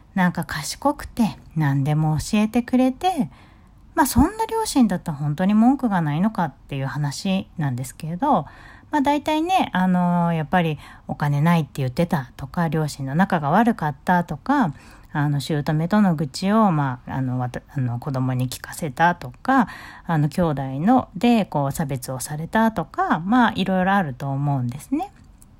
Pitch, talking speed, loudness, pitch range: 170 Hz, 315 characters per minute, -22 LUFS, 140-220 Hz